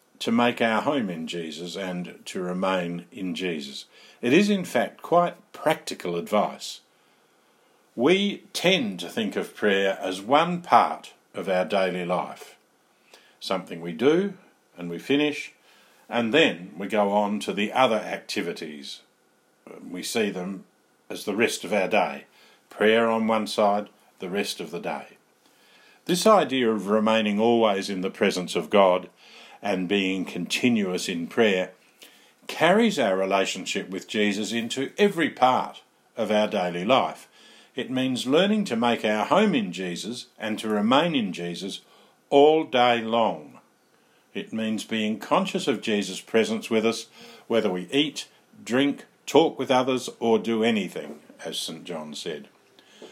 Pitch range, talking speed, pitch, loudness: 95-130 Hz, 150 wpm, 110 Hz, -24 LUFS